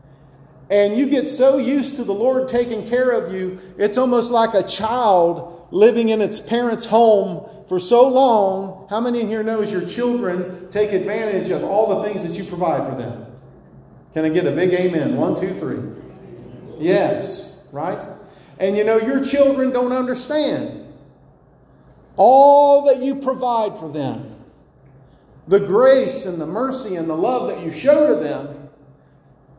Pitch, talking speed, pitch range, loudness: 210 Hz, 160 wpm, 180-250 Hz, -18 LUFS